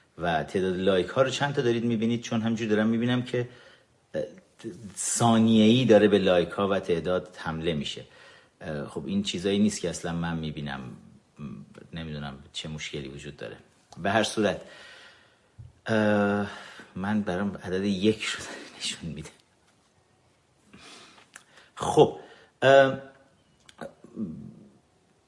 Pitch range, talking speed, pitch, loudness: 85-120 Hz, 115 wpm, 105 Hz, -26 LUFS